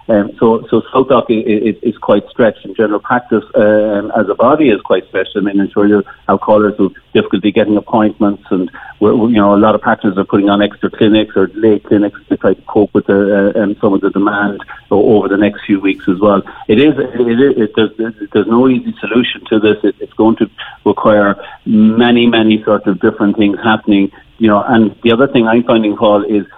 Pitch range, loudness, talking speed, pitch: 100-115 Hz, -12 LUFS, 230 wpm, 105 Hz